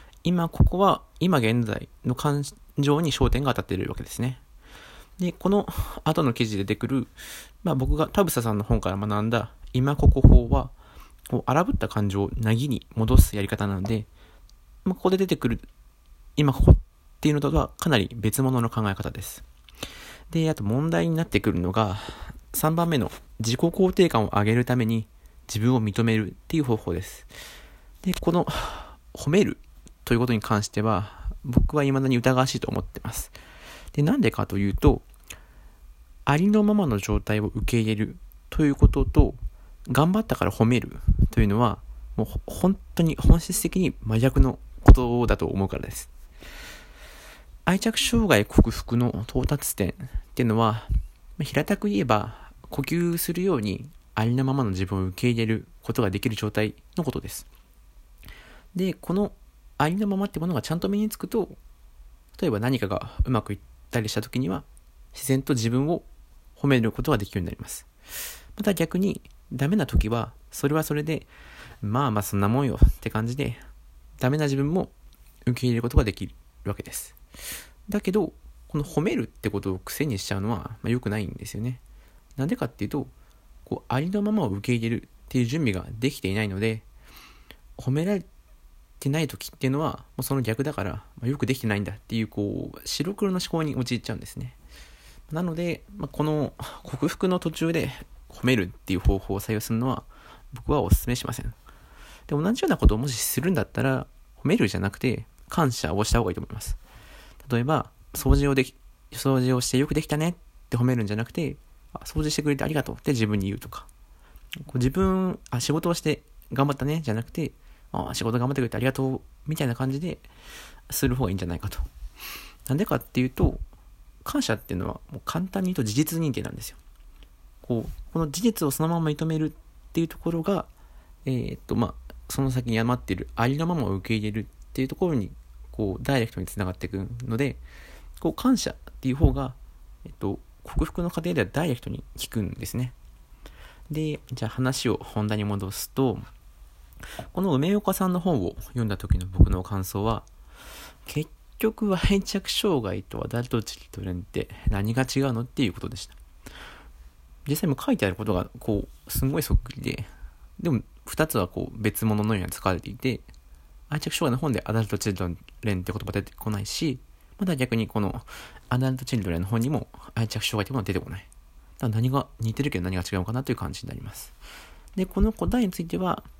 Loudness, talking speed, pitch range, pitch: -26 LUFS, 360 characters per minute, 100-145 Hz, 120 Hz